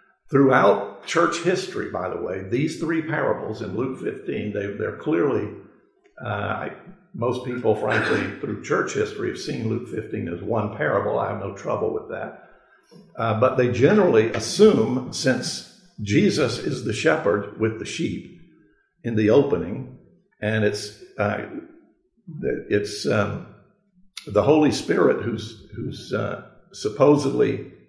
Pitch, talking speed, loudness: 140 Hz, 135 wpm, -23 LUFS